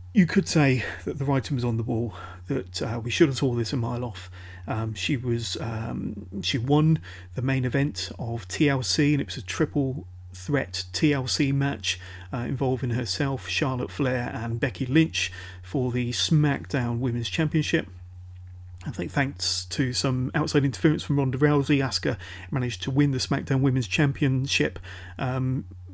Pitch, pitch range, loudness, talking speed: 125 Hz, 95-140 Hz, -26 LUFS, 160 wpm